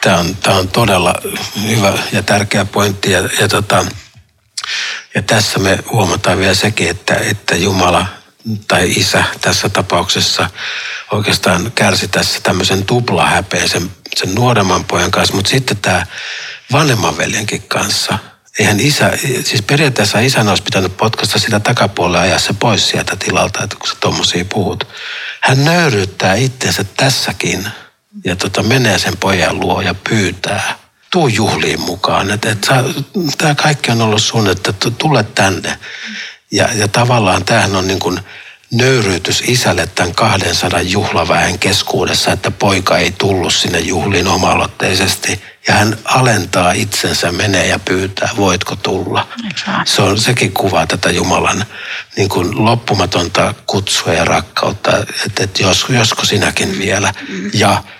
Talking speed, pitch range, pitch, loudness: 135 wpm, 95-115 Hz, 100 Hz, -13 LUFS